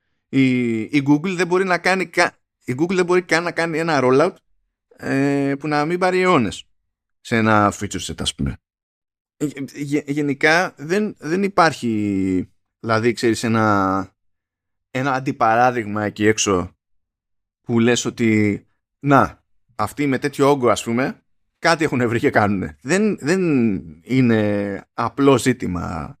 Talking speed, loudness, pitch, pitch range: 140 wpm, -19 LUFS, 120 Hz, 100-145 Hz